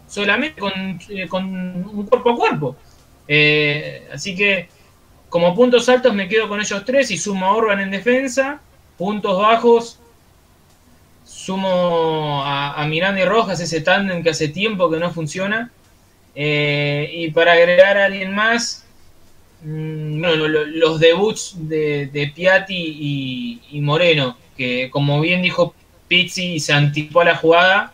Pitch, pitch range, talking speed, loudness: 170 Hz, 145-195 Hz, 150 wpm, -17 LUFS